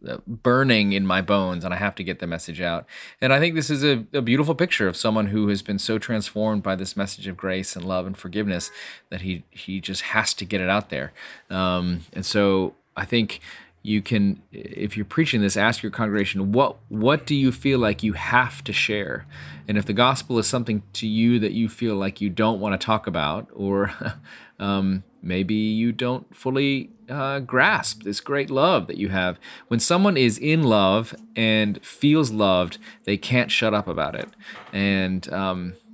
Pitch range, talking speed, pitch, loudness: 95-120 Hz, 200 wpm, 105 Hz, -22 LUFS